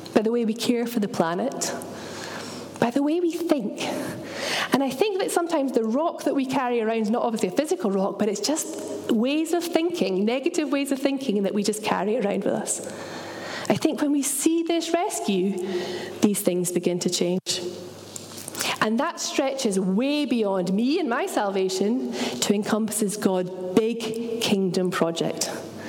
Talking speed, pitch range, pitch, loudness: 170 wpm, 200-295 Hz, 235 Hz, -25 LUFS